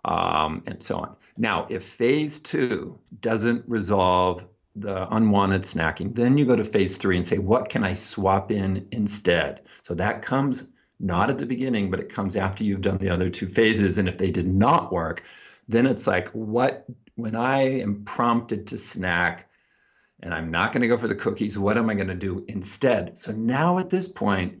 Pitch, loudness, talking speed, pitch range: 105 Hz, -24 LUFS, 200 wpm, 95-120 Hz